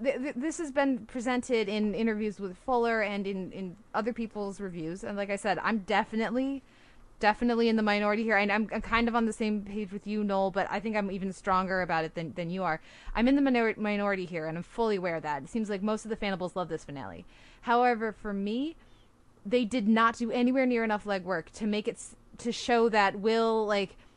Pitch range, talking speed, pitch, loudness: 195-230 Hz, 225 wpm, 210 Hz, -30 LUFS